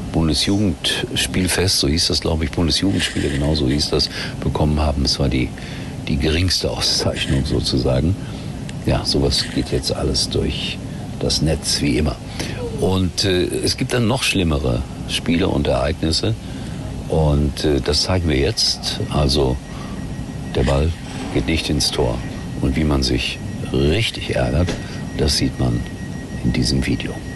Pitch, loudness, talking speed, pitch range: 75 Hz, -19 LUFS, 145 wpm, 65-90 Hz